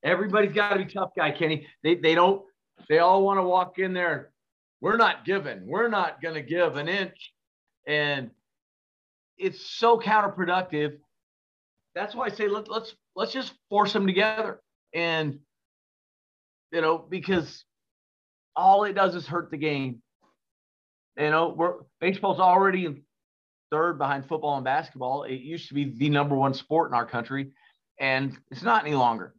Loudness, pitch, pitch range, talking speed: -25 LUFS, 160 Hz, 135-190 Hz, 160 wpm